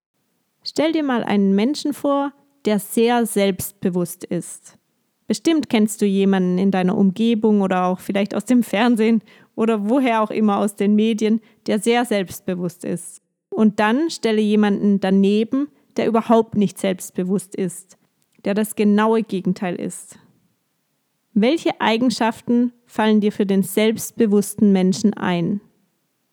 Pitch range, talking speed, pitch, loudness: 195-230 Hz, 130 wpm, 210 Hz, -19 LUFS